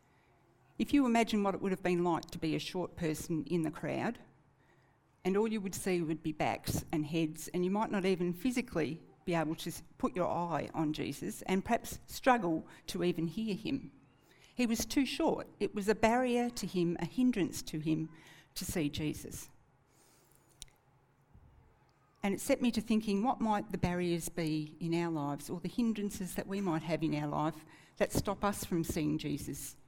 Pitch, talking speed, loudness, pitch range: 175 Hz, 190 wpm, -35 LUFS, 160-210 Hz